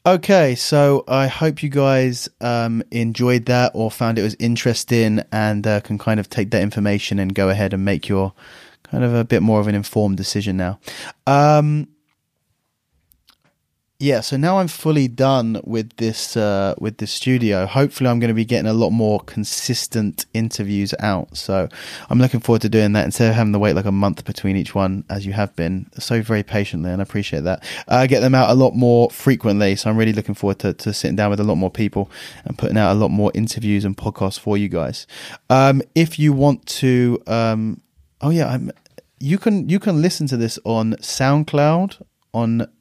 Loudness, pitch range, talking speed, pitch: -18 LUFS, 105-130 Hz, 205 wpm, 115 Hz